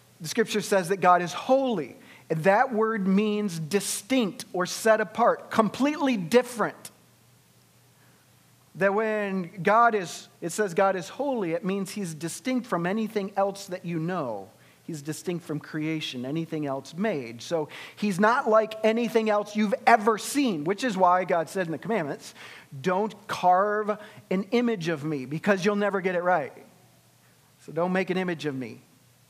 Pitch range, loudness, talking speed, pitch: 160-215 Hz, -26 LUFS, 160 wpm, 190 Hz